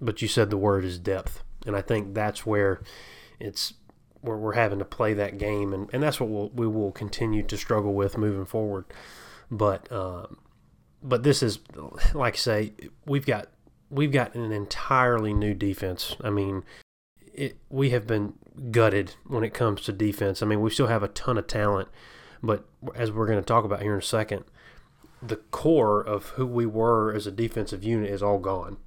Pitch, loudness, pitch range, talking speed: 105 Hz, -27 LUFS, 100-115 Hz, 195 wpm